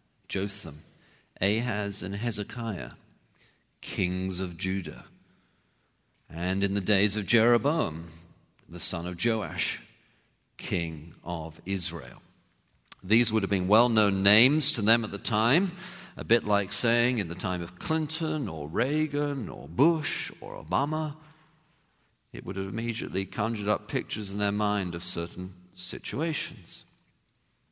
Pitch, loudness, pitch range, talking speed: 105 Hz, -28 LUFS, 90-120 Hz, 130 wpm